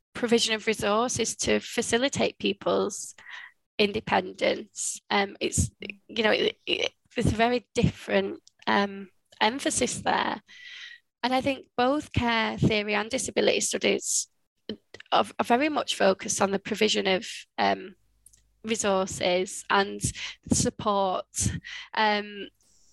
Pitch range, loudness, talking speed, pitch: 200-245 Hz, -26 LUFS, 115 wpm, 220 Hz